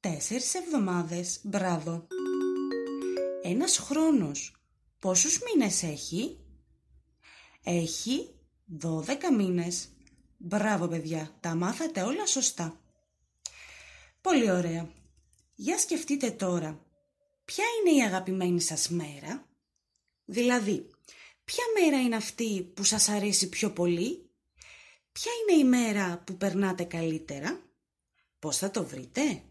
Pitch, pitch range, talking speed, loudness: 190 Hz, 170-270 Hz, 100 wpm, -29 LUFS